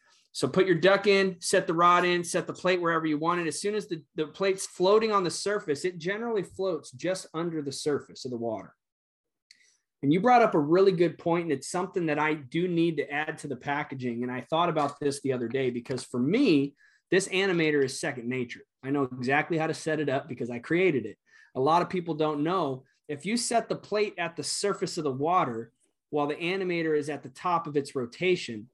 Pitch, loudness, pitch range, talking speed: 160 Hz, -28 LUFS, 140-185 Hz, 230 wpm